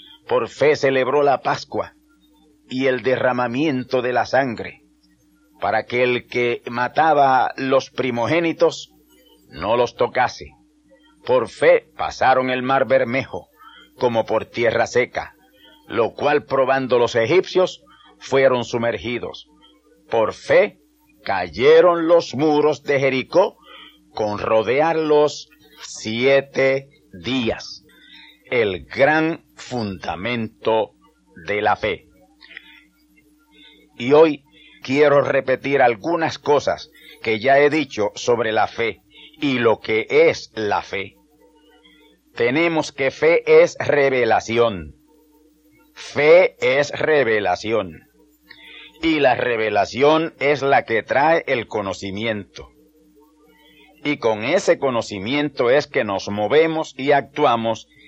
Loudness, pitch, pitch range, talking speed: -19 LUFS, 145 Hz, 125-155 Hz, 105 wpm